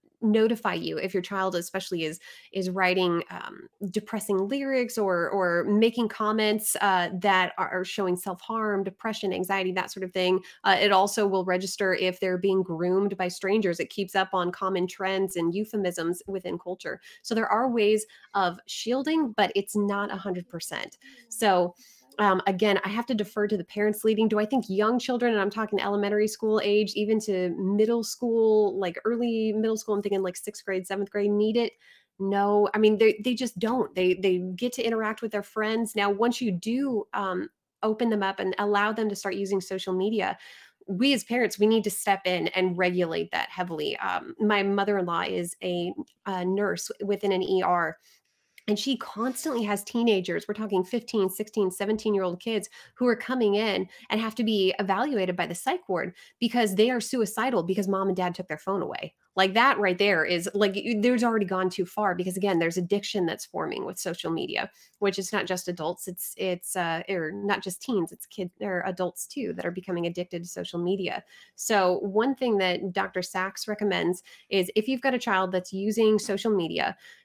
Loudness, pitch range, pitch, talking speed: -27 LUFS, 185-220 Hz, 200 Hz, 195 wpm